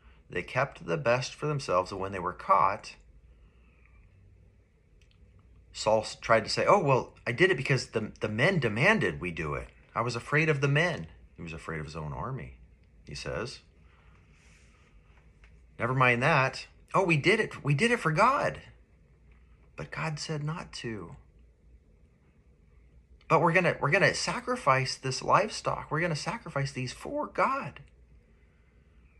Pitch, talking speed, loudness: 85 Hz, 150 wpm, -28 LUFS